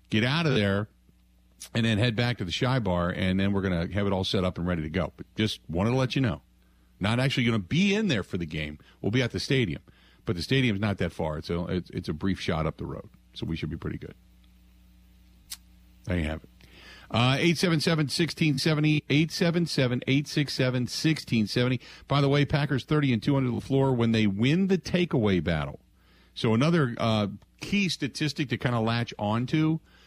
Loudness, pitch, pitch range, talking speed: -27 LUFS, 115 Hz, 90-140 Hz, 210 wpm